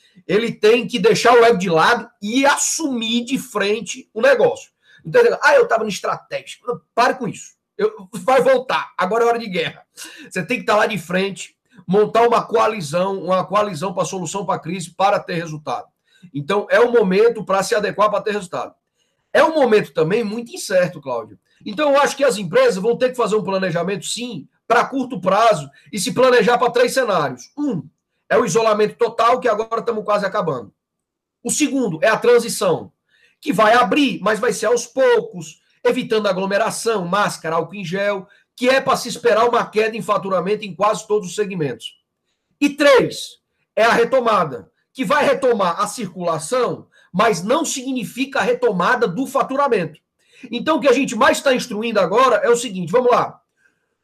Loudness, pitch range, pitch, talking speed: -18 LUFS, 200-255 Hz, 225 Hz, 185 wpm